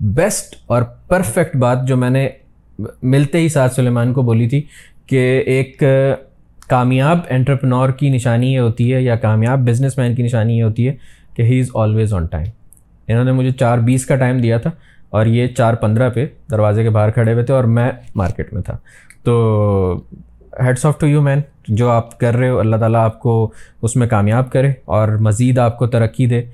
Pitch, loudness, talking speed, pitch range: 120 Hz, -15 LUFS, 200 wpm, 115-130 Hz